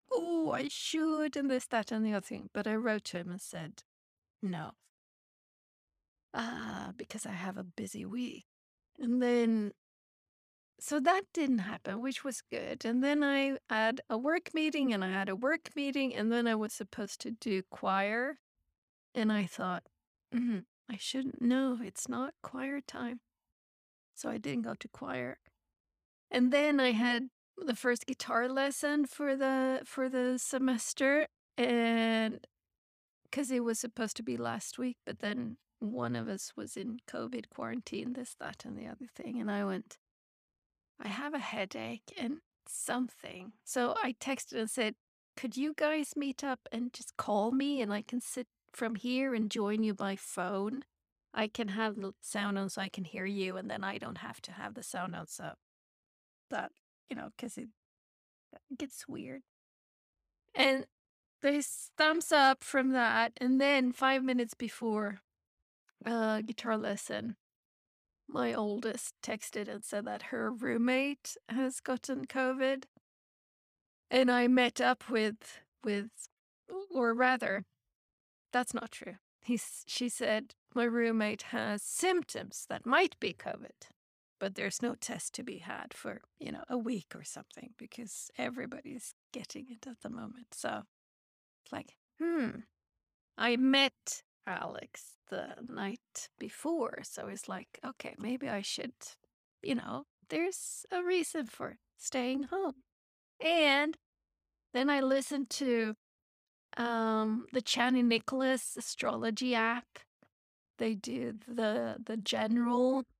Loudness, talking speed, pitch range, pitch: -34 LUFS, 150 wpm, 220-265 Hz, 245 Hz